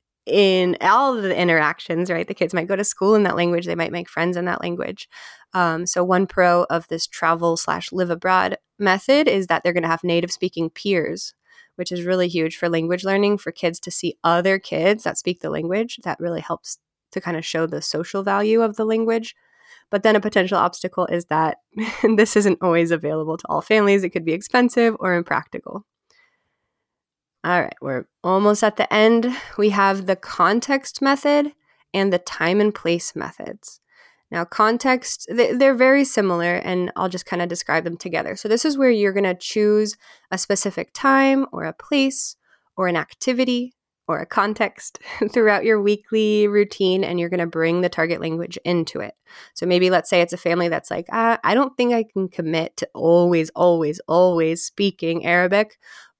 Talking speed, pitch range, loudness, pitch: 185 wpm, 170-220 Hz, -20 LUFS, 185 Hz